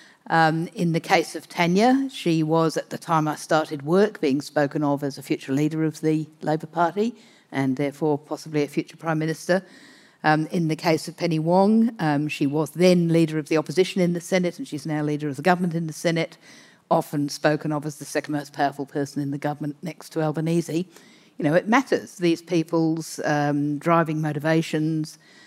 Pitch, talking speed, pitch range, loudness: 160 Hz, 200 wpm, 150-170 Hz, -23 LUFS